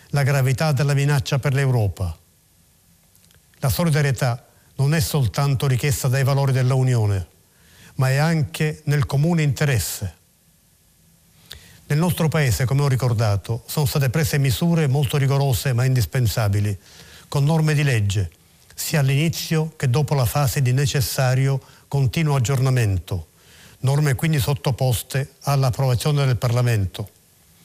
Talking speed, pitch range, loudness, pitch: 120 wpm, 115-145 Hz, -21 LUFS, 135 Hz